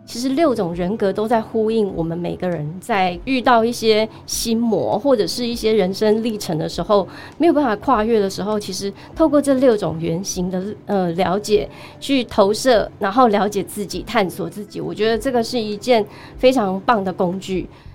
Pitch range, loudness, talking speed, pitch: 185-235 Hz, -19 LUFS, 275 characters per minute, 210 Hz